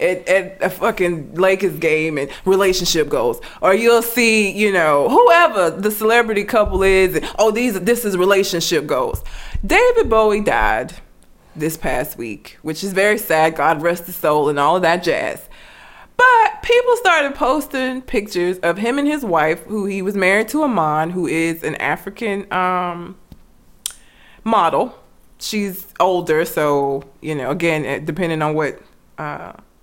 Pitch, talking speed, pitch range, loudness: 195 Hz, 155 wpm, 170-235 Hz, -17 LUFS